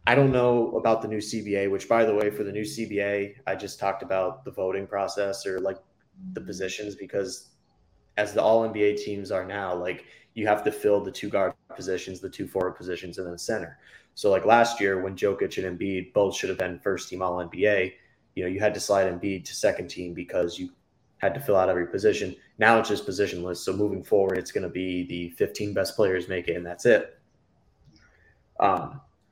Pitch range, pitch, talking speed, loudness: 90-105 Hz, 100 Hz, 215 wpm, -26 LUFS